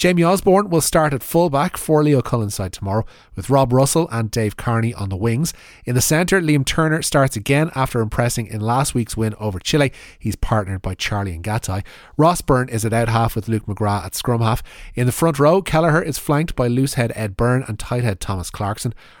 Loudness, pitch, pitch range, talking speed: -19 LUFS, 120 Hz, 110-150 Hz, 215 wpm